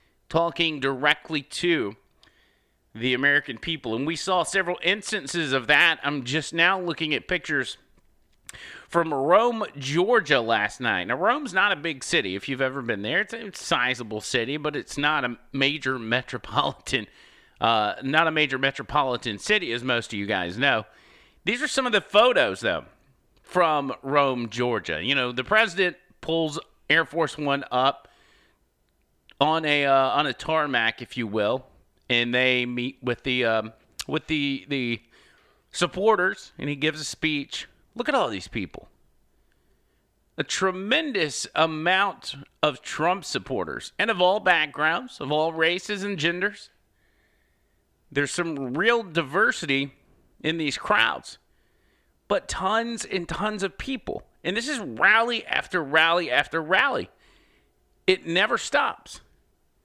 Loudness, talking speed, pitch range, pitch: -24 LUFS, 145 wpm, 130-175 Hz, 150 Hz